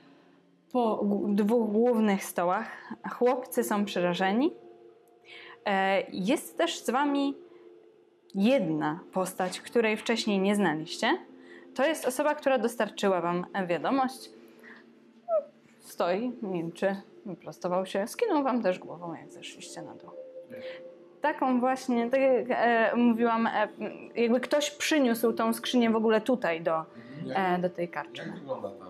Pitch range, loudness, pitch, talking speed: 190-265 Hz, -28 LUFS, 230 Hz, 110 wpm